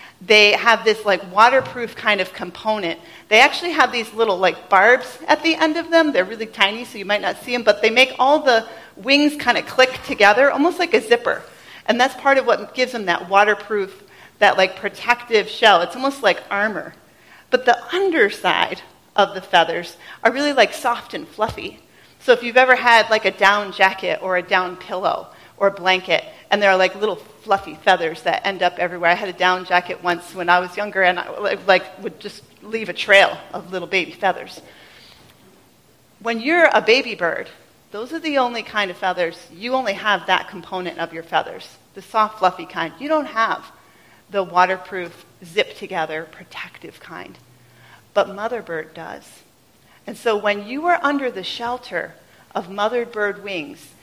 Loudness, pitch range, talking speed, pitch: -18 LUFS, 185-240 Hz, 190 wpm, 205 Hz